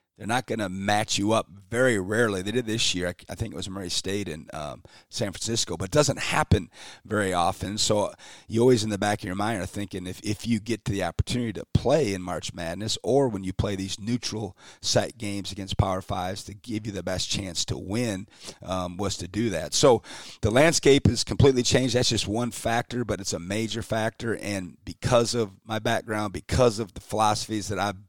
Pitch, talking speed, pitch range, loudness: 105 Hz, 220 wpm, 95-115 Hz, -26 LUFS